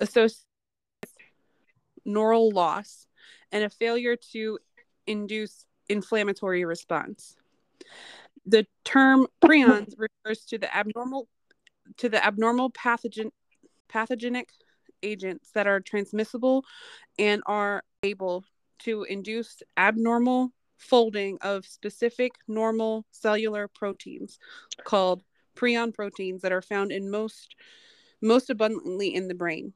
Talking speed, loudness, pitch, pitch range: 105 wpm, -26 LUFS, 220 Hz, 205-245 Hz